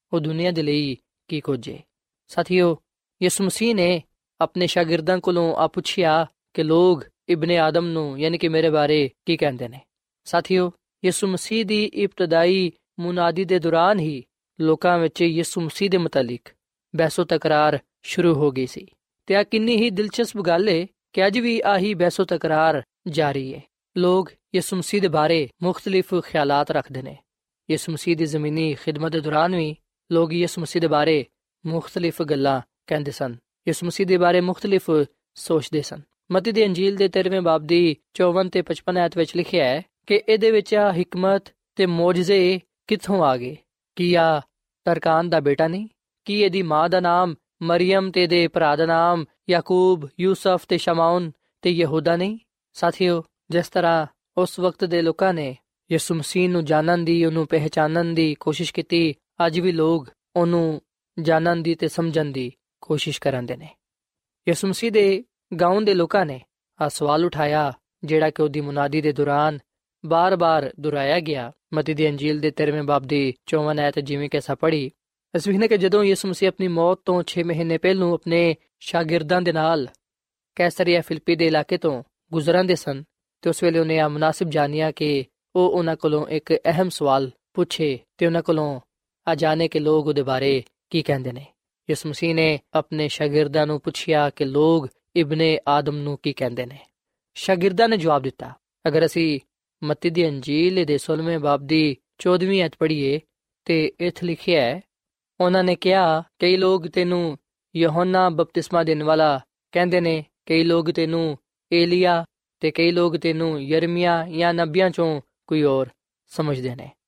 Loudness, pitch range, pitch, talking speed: -21 LUFS, 155-180 Hz, 165 Hz, 160 wpm